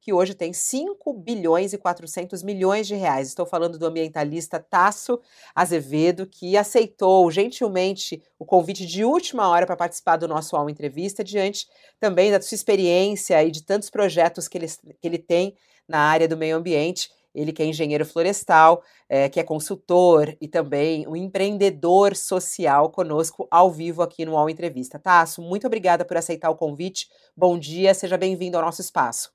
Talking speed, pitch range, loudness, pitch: 170 wpm, 165-195 Hz, -21 LUFS, 175 Hz